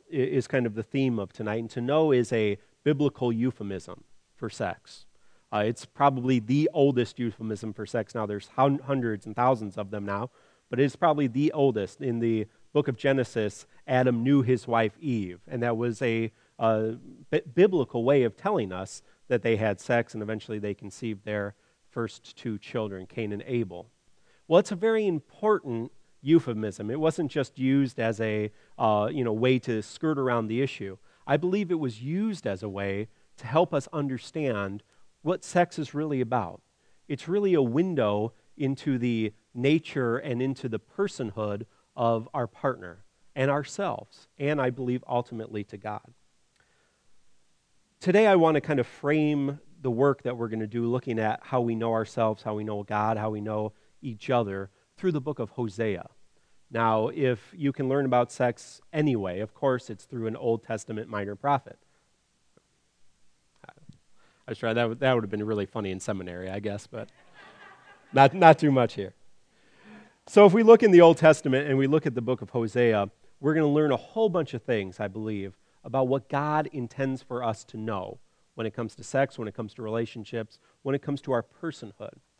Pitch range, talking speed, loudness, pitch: 110-140 Hz, 185 wpm, -27 LUFS, 120 Hz